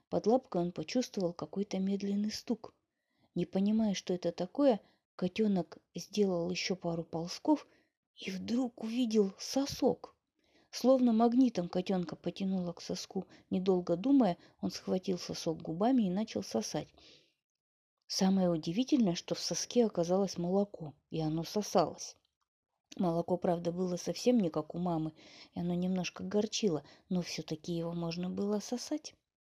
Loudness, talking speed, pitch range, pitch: -34 LUFS, 130 wpm, 175-215 Hz, 185 Hz